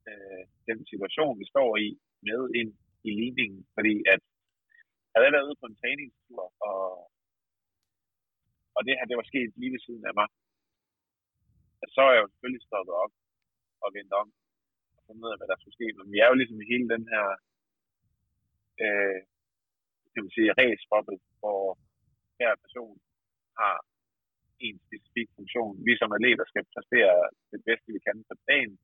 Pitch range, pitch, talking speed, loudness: 95-115 Hz, 105 Hz, 170 wpm, -27 LUFS